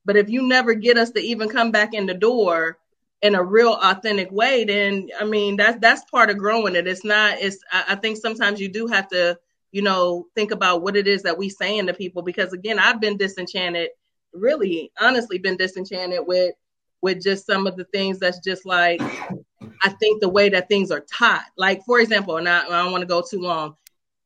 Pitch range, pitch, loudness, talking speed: 180-215 Hz, 195 Hz, -19 LUFS, 225 wpm